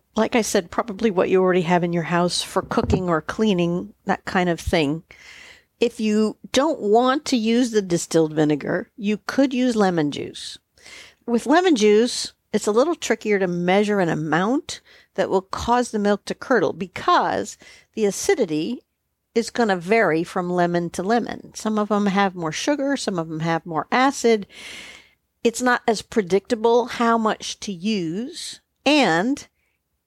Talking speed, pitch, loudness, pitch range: 165 wpm, 210 Hz, -21 LUFS, 180-240 Hz